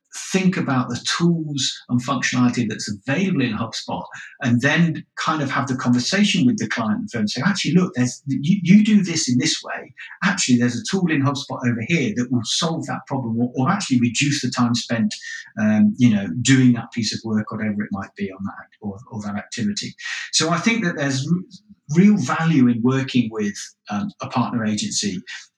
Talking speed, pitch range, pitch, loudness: 200 wpm, 120-180 Hz, 130 Hz, -20 LUFS